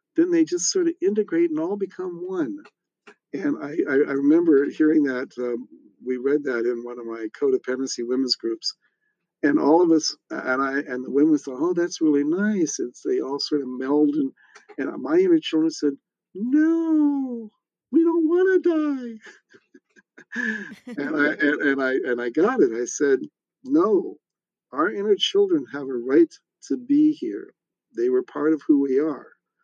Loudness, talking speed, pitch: -22 LUFS, 180 wpm, 270 Hz